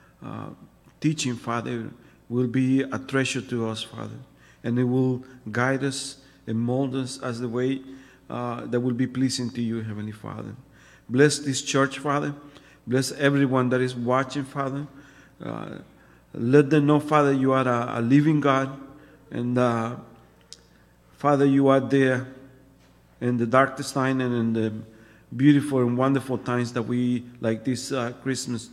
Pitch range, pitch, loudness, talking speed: 120-135 Hz, 130 Hz, -24 LUFS, 155 wpm